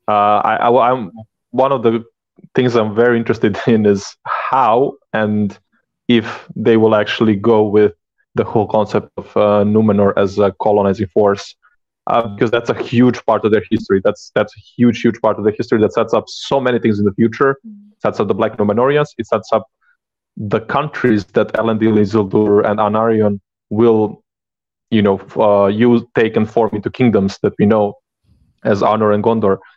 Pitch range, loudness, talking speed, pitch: 105-115 Hz, -15 LUFS, 185 wpm, 110 Hz